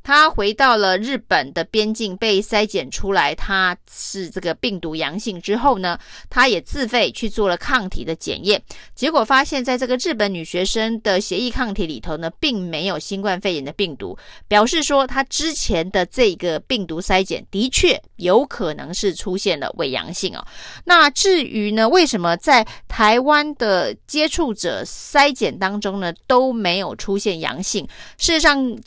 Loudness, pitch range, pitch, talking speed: -18 LUFS, 185-260 Hz, 210 Hz, 255 characters per minute